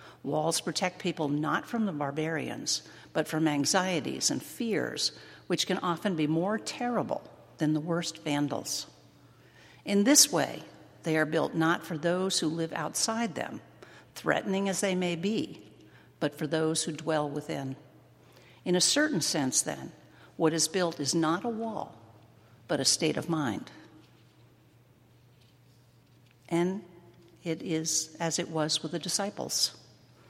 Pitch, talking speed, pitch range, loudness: 160 Hz, 145 wpm, 150-180 Hz, -29 LUFS